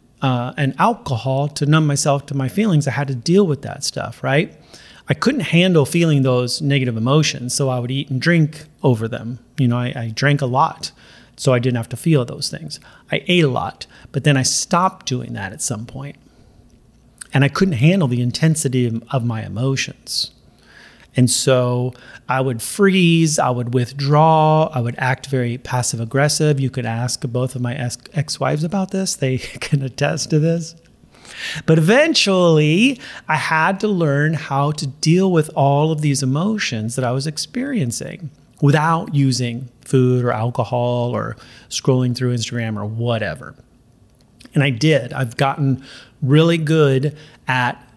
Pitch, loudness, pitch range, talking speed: 135 Hz, -18 LUFS, 125-155 Hz, 170 wpm